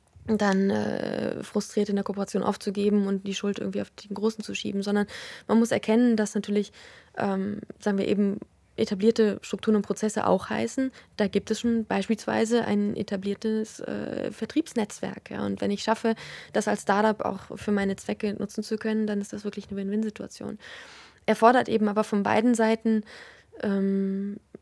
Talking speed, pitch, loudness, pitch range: 170 wpm, 210 Hz, -27 LUFS, 200-220 Hz